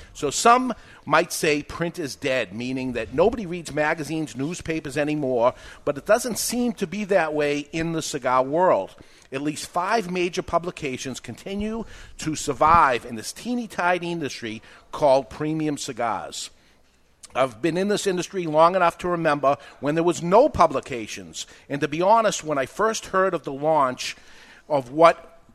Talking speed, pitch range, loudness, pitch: 160 wpm, 145-180 Hz, -23 LUFS, 160 Hz